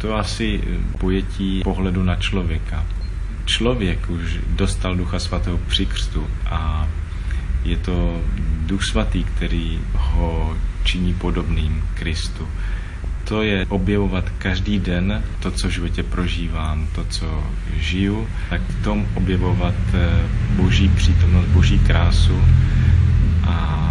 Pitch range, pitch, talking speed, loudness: 85-95 Hz, 90 Hz, 110 wpm, -21 LUFS